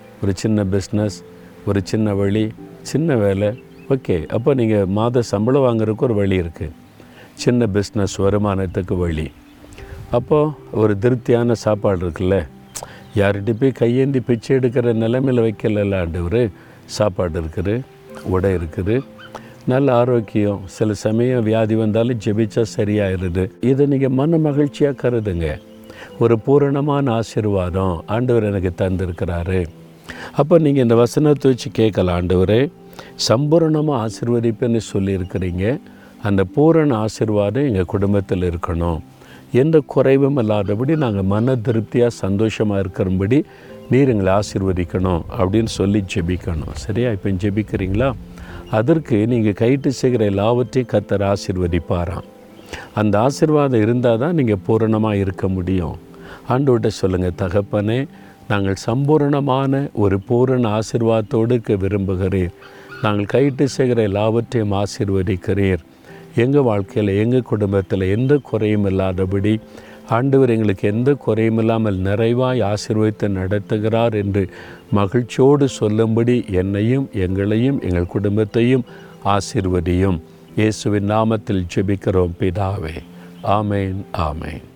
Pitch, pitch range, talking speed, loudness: 105 Hz, 95-125 Hz, 105 wpm, -18 LUFS